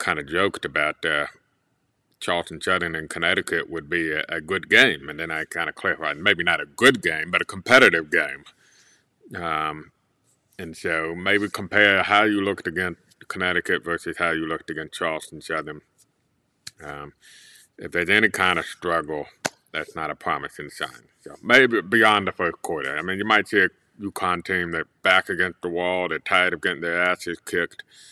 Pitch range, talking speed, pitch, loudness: 80-95 Hz, 180 wpm, 85 Hz, -22 LUFS